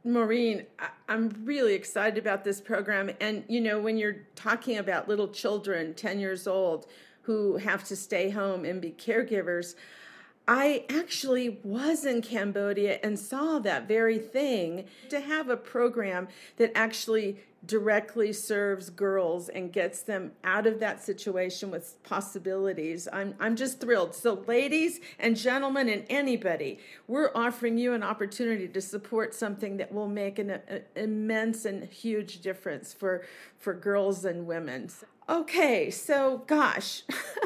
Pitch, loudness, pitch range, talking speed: 210 Hz, -30 LUFS, 195-235 Hz, 145 wpm